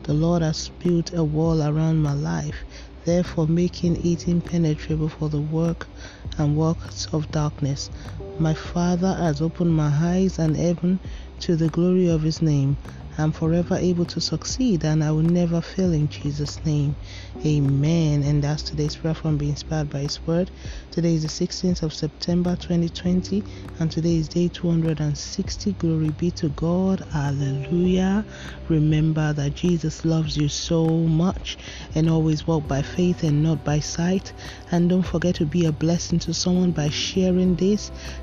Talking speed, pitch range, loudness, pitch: 160 wpm, 150-175 Hz, -23 LUFS, 160 Hz